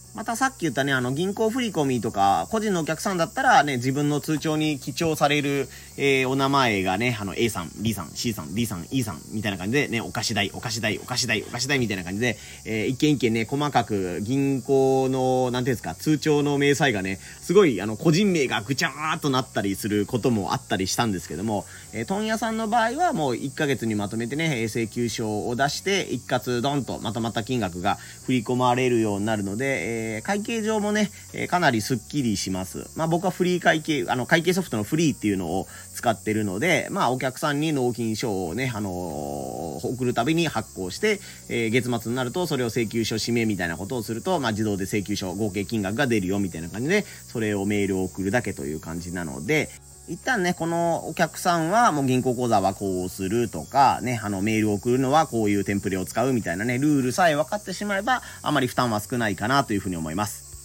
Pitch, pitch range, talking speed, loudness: 125 Hz, 105-145 Hz, 435 characters per minute, -24 LUFS